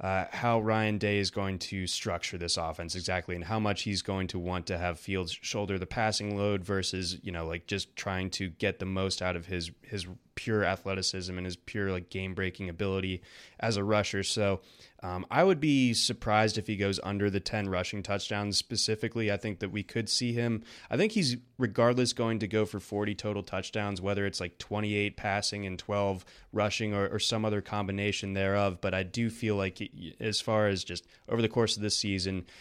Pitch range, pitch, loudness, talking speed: 95-110 Hz, 100 Hz, -31 LUFS, 210 wpm